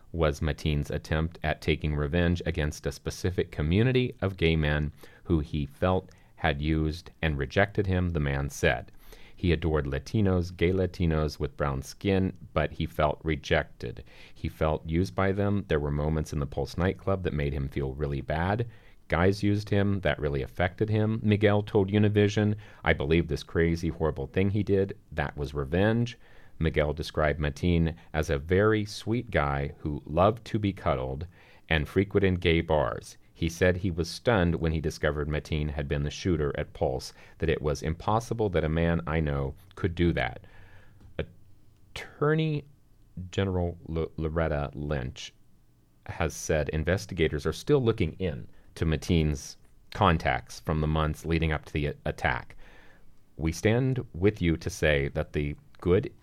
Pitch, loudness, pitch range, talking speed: 85 Hz, -28 LUFS, 75-100 Hz, 160 wpm